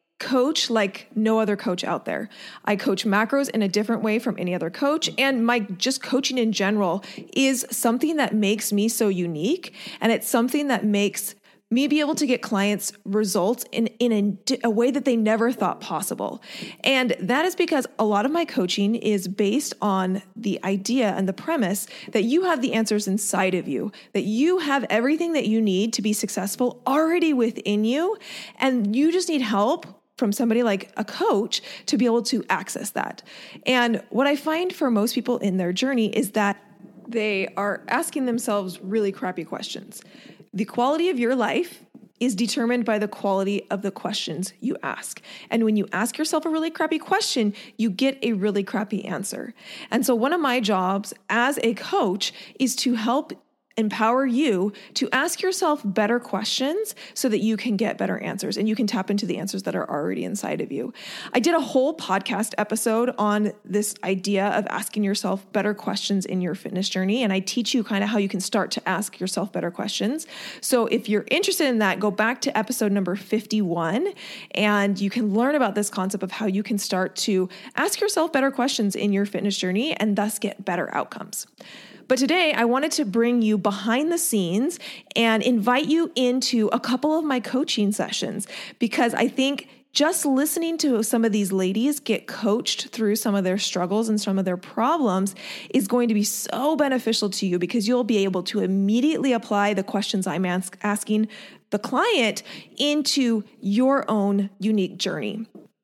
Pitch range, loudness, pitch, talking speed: 200-260 Hz, -23 LUFS, 220 Hz, 190 wpm